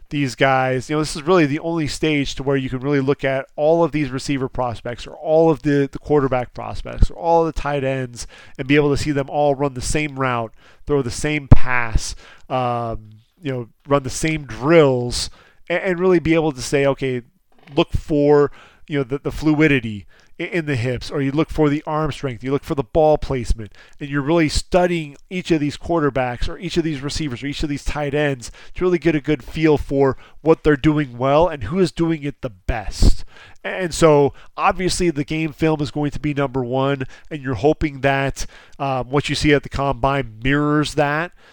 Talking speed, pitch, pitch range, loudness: 215 wpm, 145 Hz, 135-155 Hz, -20 LUFS